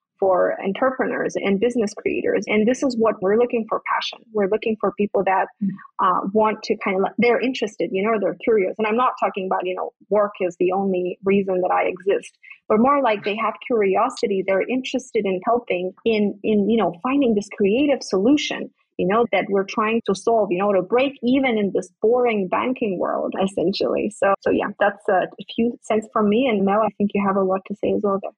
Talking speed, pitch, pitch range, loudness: 220 wpm, 215 Hz, 195-240 Hz, -21 LUFS